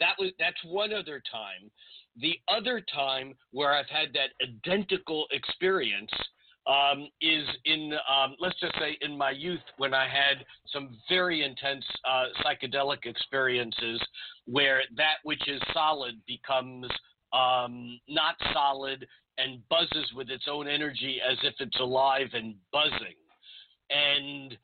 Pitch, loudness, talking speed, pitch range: 140 Hz, -28 LUFS, 135 wpm, 130-155 Hz